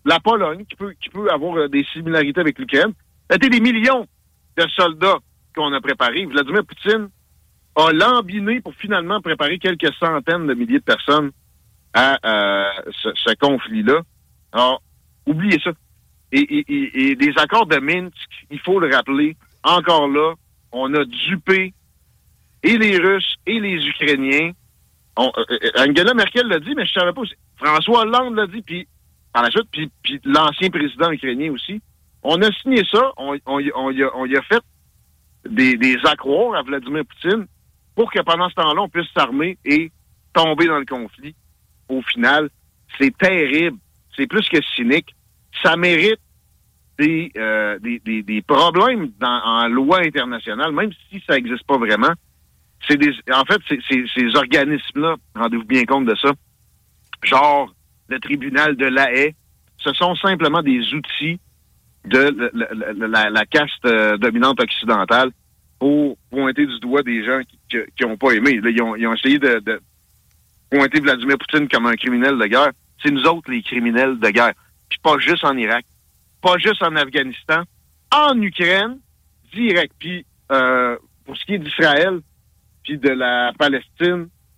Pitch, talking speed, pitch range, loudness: 150 Hz, 165 wpm, 125-185 Hz, -17 LUFS